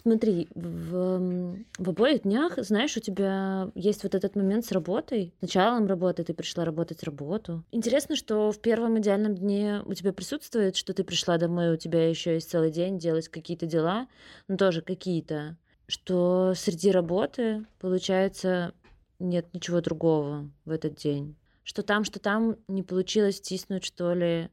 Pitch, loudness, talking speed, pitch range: 185 Hz, -28 LUFS, 160 wpm, 170-205 Hz